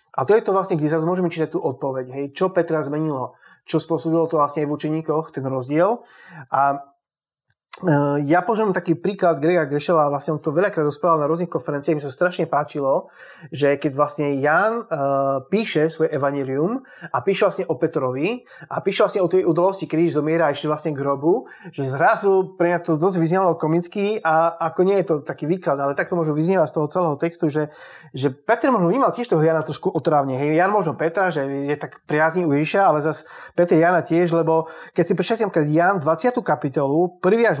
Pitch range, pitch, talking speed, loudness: 150-180 Hz, 160 Hz, 205 wpm, -20 LUFS